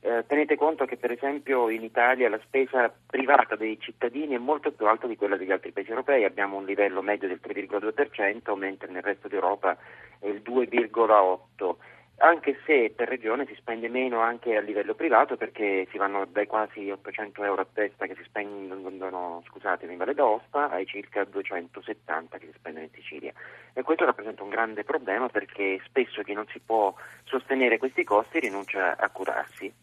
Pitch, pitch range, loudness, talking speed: 105 Hz, 100-120 Hz, -27 LUFS, 180 wpm